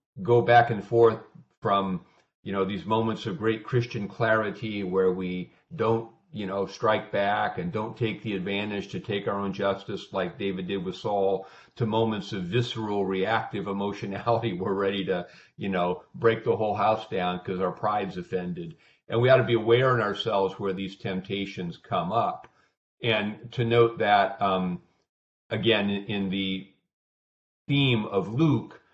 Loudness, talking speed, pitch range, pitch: -27 LUFS, 165 wpm, 95-115 Hz, 100 Hz